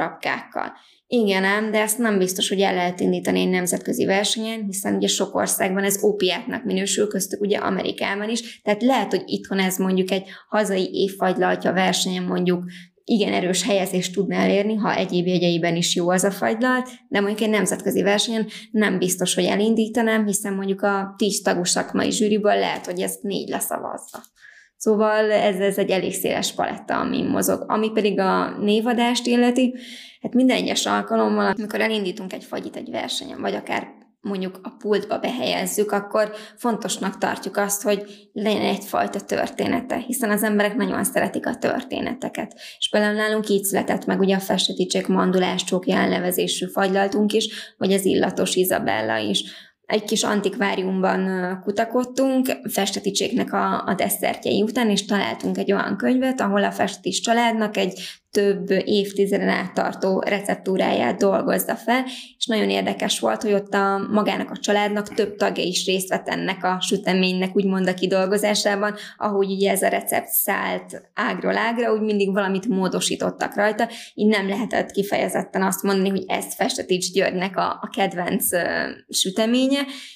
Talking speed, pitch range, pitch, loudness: 155 wpm, 190-215 Hz, 200 Hz, -22 LUFS